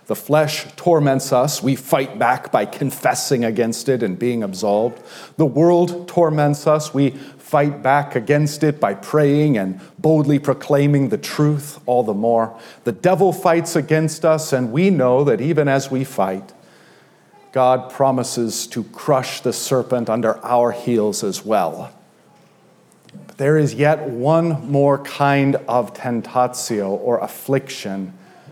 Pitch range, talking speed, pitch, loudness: 125-155 Hz, 145 wpm, 140 Hz, -18 LUFS